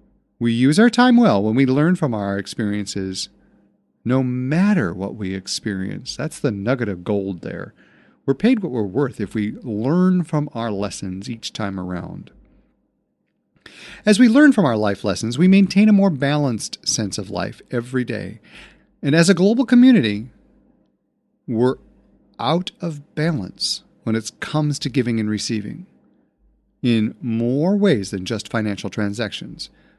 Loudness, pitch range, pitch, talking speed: -19 LUFS, 105-165 Hz, 120 Hz, 150 wpm